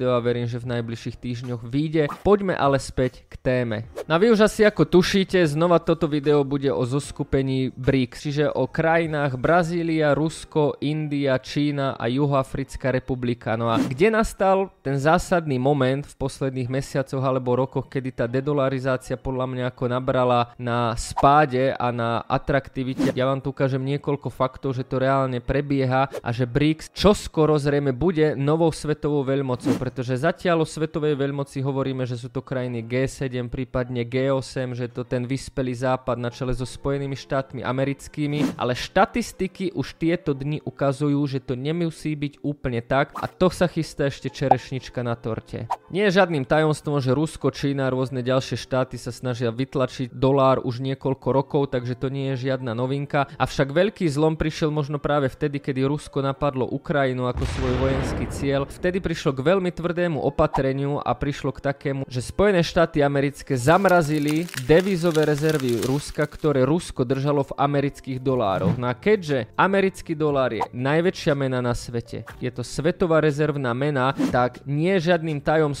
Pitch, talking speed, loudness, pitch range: 140 Hz, 165 wpm, -23 LUFS, 130-155 Hz